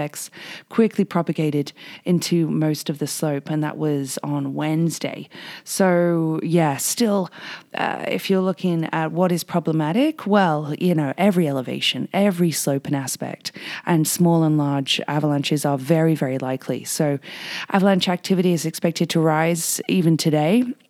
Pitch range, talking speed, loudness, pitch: 150-180 Hz, 145 wpm, -21 LUFS, 160 Hz